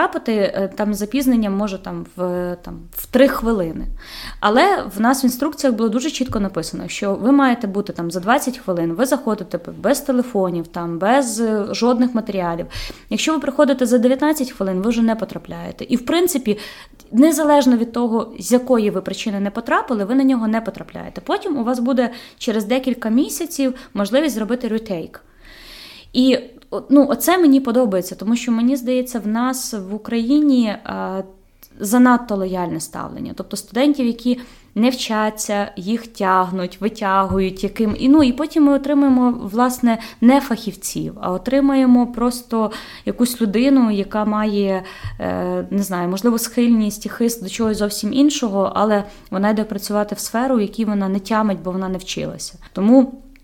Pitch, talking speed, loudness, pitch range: 230 Hz, 155 wpm, -18 LUFS, 200-255 Hz